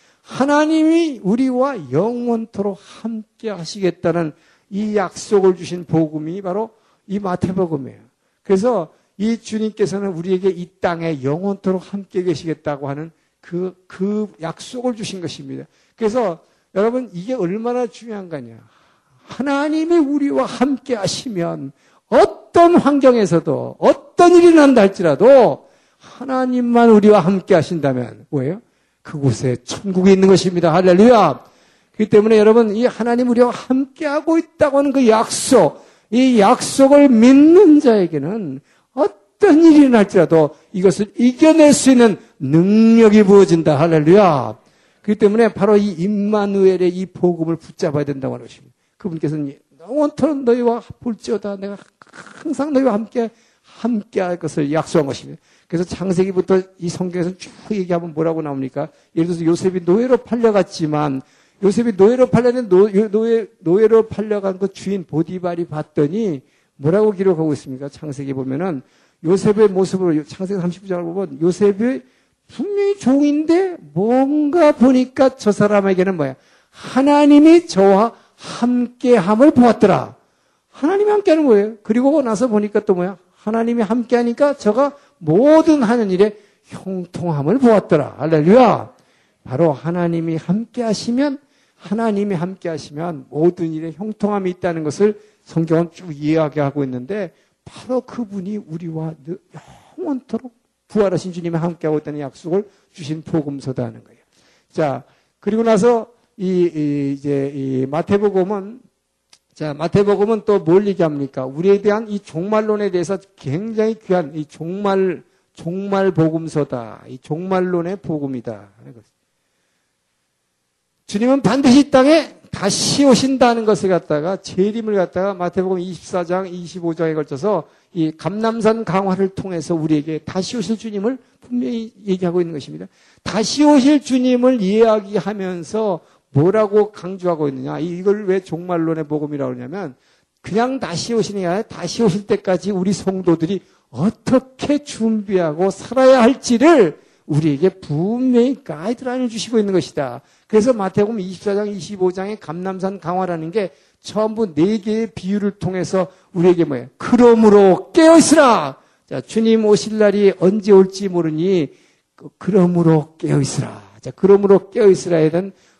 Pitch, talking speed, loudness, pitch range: 195 Hz, 315 characters per minute, -16 LUFS, 170-230 Hz